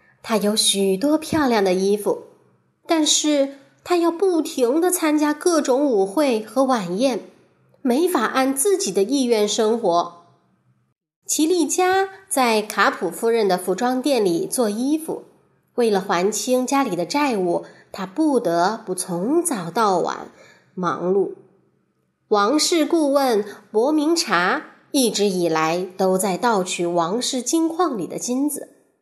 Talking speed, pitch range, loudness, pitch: 190 characters per minute, 195-310 Hz, -20 LUFS, 250 Hz